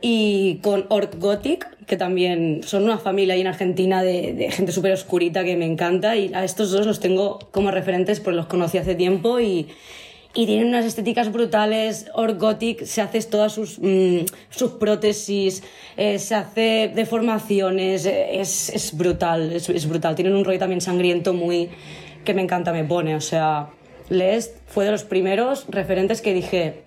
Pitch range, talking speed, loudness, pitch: 180-215 Hz, 175 wpm, -21 LUFS, 195 Hz